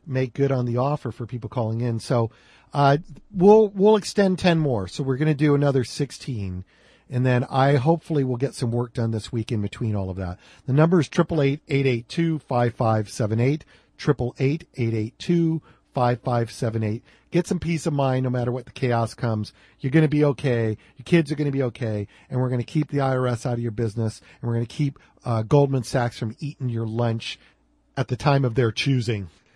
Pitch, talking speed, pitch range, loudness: 125 Hz, 195 wpm, 115-145 Hz, -23 LUFS